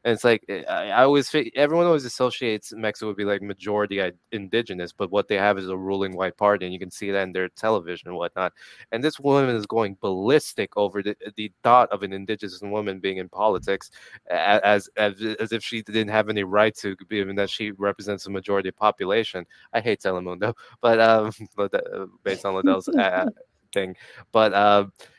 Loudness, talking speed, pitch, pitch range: -23 LUFS, 205 wpm, 105 Hz, 100-110 Hz